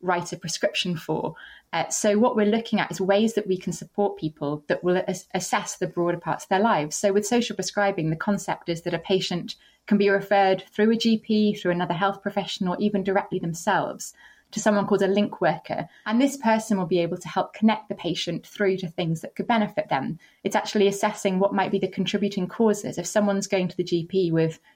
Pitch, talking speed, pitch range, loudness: 195 Hz, 220 wpm, 180-210 Hz, -24 LUFS